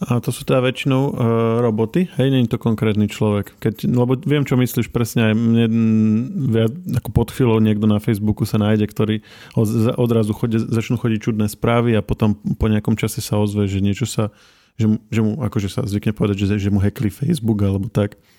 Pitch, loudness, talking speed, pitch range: 110 Hz, -19 LUFS, 200 wpm, 105-120 Hz